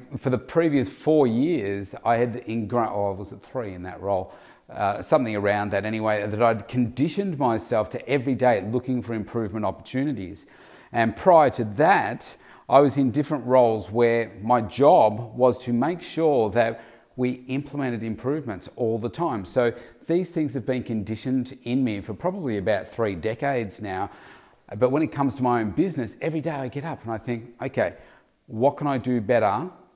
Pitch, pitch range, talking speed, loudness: 120 Hz, 110-135 Hz, 180 wpm, -24 LUFS